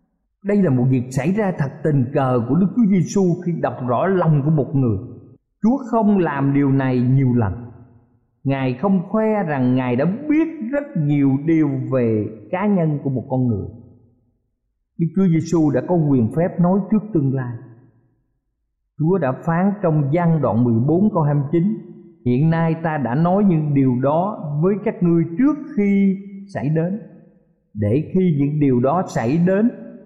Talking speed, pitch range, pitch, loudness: 170 wpm, 130-185 Hz, 155 Hz, -19 LUFS